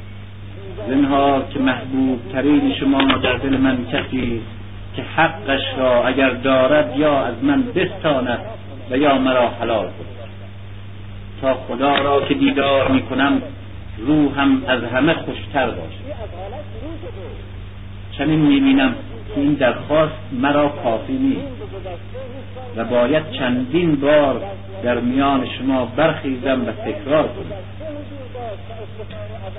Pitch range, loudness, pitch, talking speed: 100-135 Hz, -18 LUFS, 125 Hz, 110 wpm